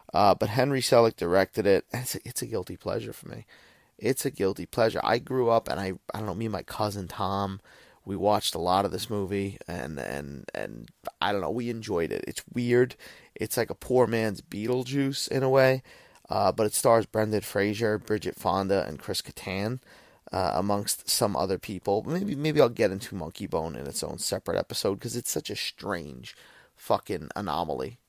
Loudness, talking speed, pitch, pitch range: -28 LUFS, 200 wpm, 105 Hz, 100-120 Hz